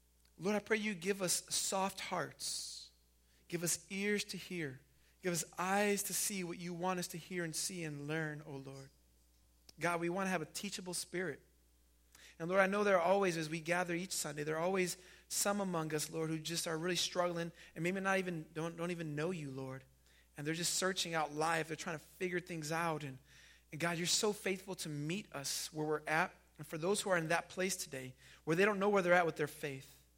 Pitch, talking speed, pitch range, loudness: 170 Hz, 230 wpm, 150-185 Hz, -37 LUFS